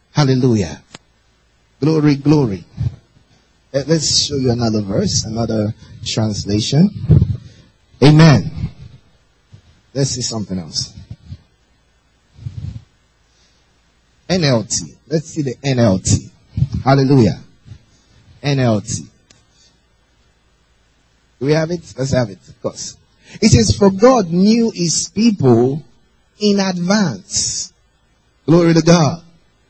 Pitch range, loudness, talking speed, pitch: 110-155 Hz, -15 LUFS, 85 wpm, 125 Hz